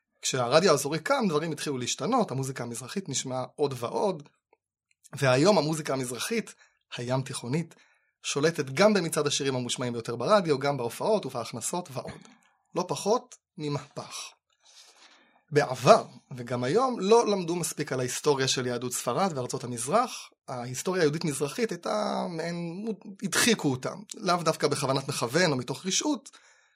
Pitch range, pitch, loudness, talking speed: 130-200 Hz, 150 Hz, -28 LUFS, 125 wpm